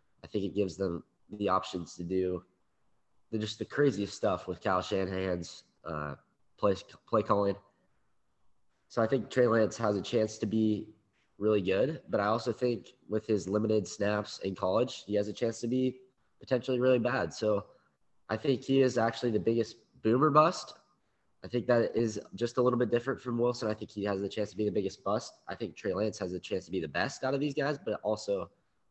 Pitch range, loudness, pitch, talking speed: 100-125 Hz, -32 LUFS, 110 Hz, 210 wpm